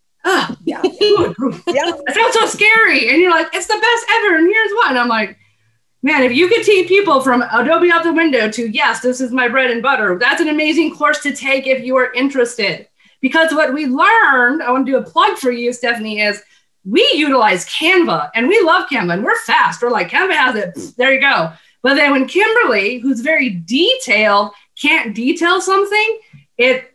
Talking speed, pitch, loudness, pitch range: 205 wpm, 275 Hz, -13 LUFS, 245-365 Hz